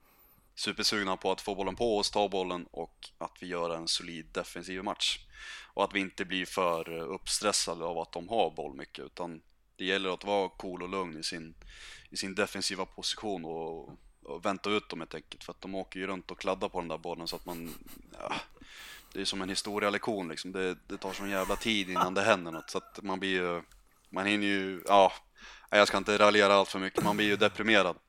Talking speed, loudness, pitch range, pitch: 220 wpm, -31 LUFS, 90-100 Hz, 95 Hz